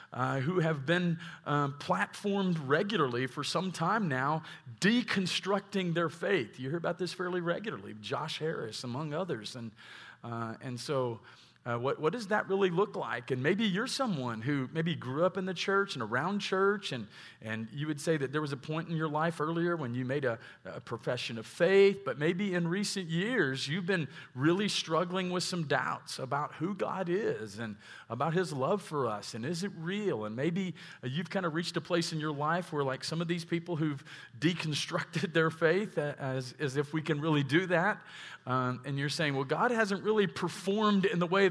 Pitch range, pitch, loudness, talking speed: 135-185 Hz, 165 Hz, -32 LUFS, 210 wpm